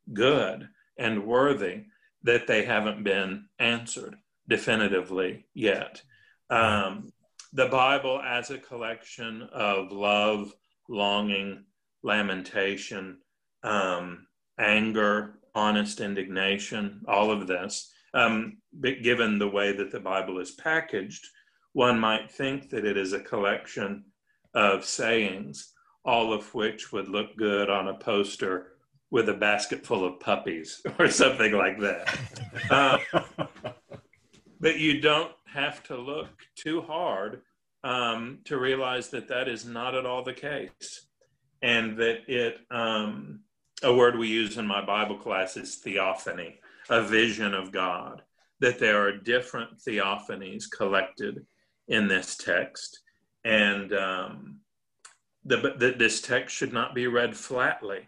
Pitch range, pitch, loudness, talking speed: 100-125 Hz, 110 Hz, -27 LUFS, 130 wpm